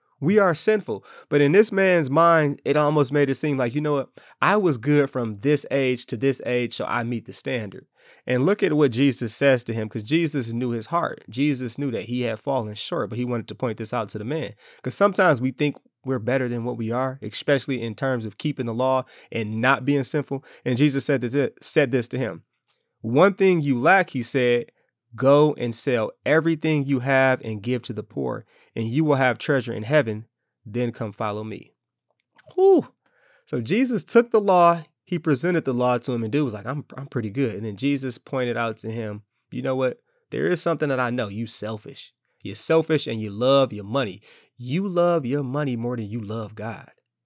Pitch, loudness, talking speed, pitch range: 130 Hz, -23 LUFS, 215 wpm, 120-150 Hz